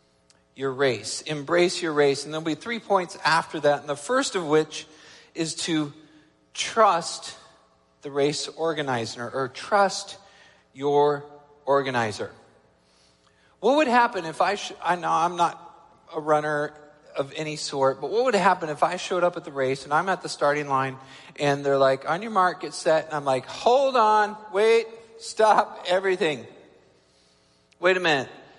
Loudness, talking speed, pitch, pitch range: -24 LUFS, 165 wpm, 150 Hz, 135-180 Hz